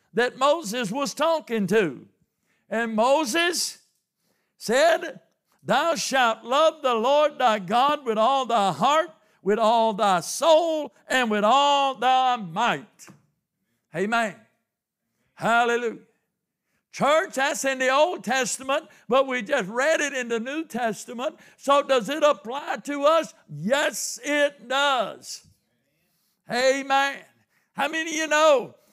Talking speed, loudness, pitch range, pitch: 125 wpm, -23 LUFS, 225-290 Hz, 260 Hz